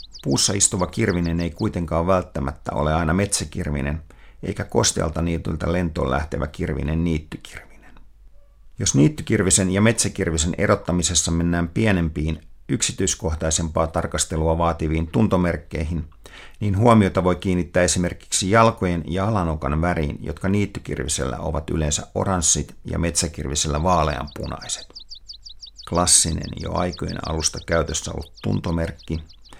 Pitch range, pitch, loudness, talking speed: 80-95 Hz, 85 Hz, -21 LUFS, 105 wpm